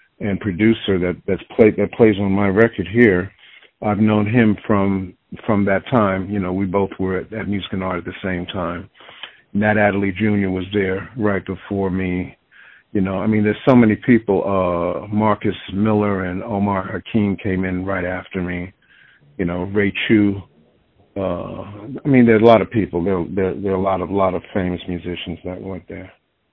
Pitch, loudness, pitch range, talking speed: 95 Hz, -19 LUFS, 95-105 Hz, 190 wpm